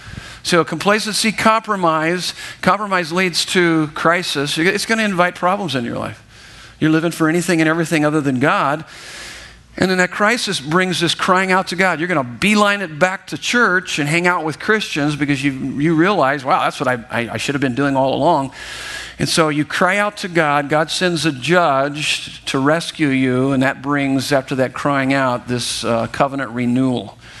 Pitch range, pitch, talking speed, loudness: 135-185 Hz, 160 Hz, 195 wpm, -17 LUFS